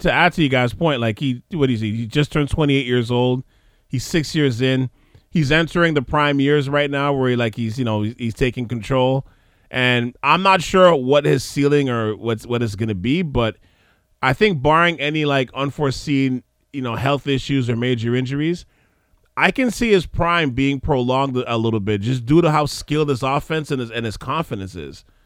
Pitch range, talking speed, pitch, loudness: 120-150 Hz, 210 wpm, 135 Hz, -19 LUFS